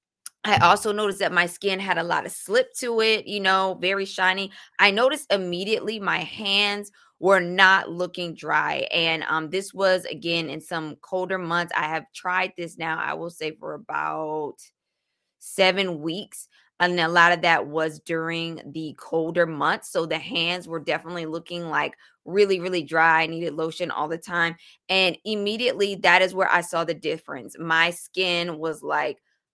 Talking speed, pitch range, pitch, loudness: 175 wpm, 165-190 Hz, 175 Hz, -23 LUFS